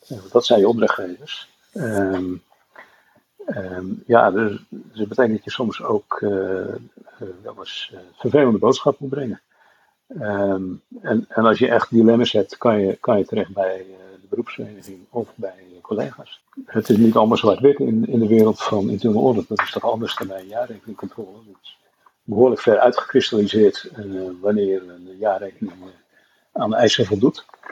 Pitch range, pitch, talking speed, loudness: 95-115 Hz, 100 Hz, 170 wpm, -19 LUFS